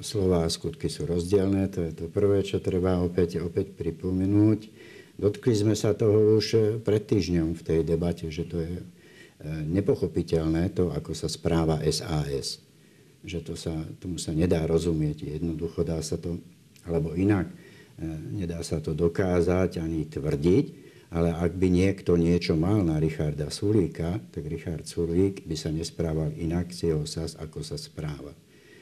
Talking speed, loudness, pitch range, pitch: 155 wpm, -27 LUFS, 80-95 Hz, 85 Hz